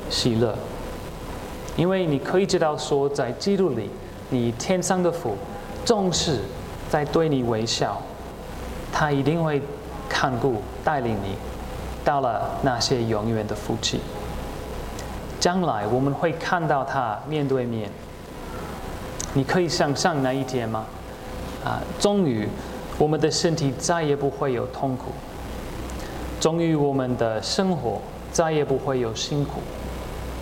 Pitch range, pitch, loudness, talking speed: 115-160 Hz, 135 Hz, -25 LUFS, 185 characters per minute